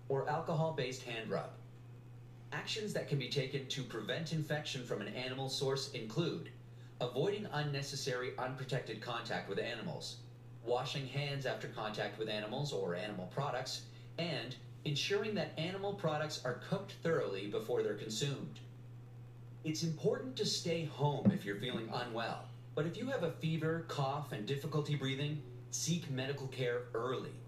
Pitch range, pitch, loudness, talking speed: 120-155 Hz, 135 Hz, -39 LUFS, 145 wpm